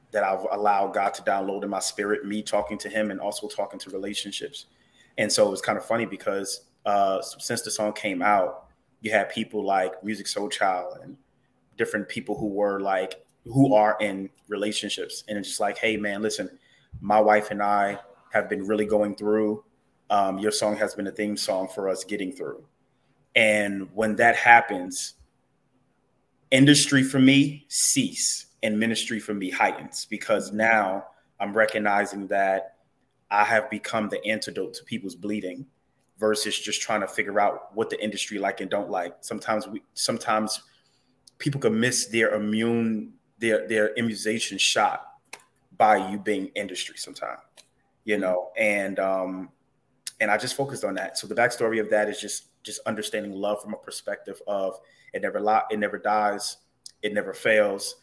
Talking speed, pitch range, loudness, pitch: 170 wpm, 100-110 Hz, -25 LUFS, 105 Hz